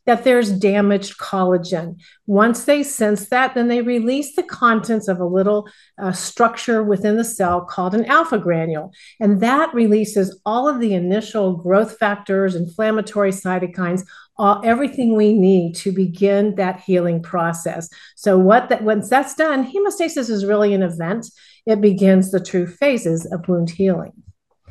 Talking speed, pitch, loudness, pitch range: 155 wpm, 205 Hz, -18 LUFS, 185-230 Hz